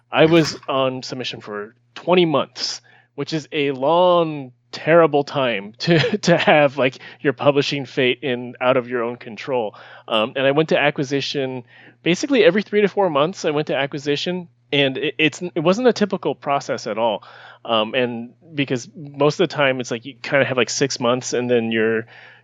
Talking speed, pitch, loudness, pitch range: 190 wpm, 140 Hz, -19 LUFS, 125-160 Hz